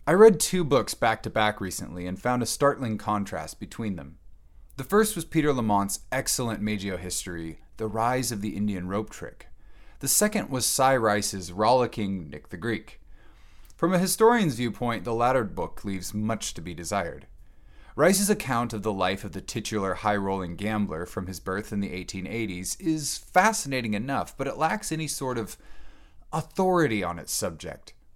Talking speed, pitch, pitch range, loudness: 175 wpm, 105 Hz, 95-130 Hz, -26 LUFS